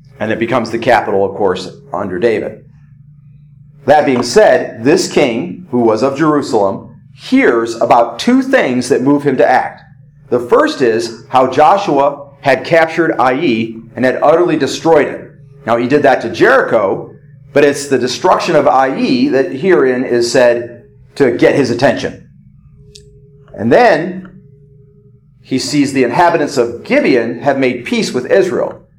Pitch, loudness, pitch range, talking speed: 140 Hz, -12 LUFS, 125-145 Hz, 150 wpm